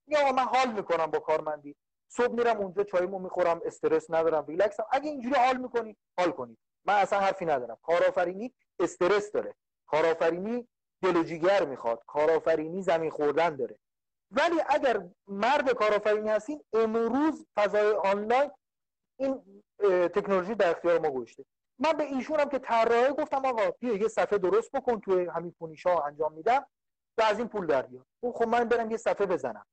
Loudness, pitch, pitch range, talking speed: -28 LUFS, 215 Hz, 175-260 Hz, 155 wpm